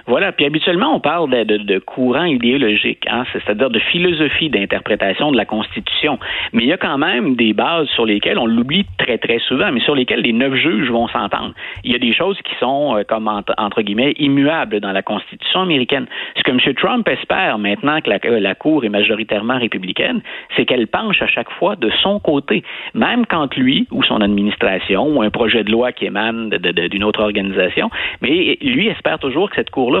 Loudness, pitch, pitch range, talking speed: -16 LUFS, 115 Hz, 105-165 Hz, 210 wpm